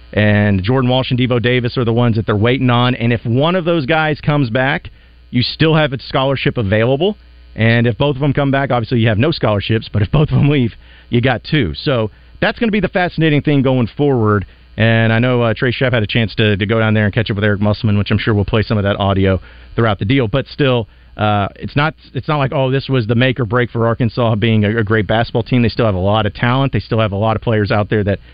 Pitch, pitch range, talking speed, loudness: 120 Hz, 105-135 Hz, 275 wpm, -15 LUFS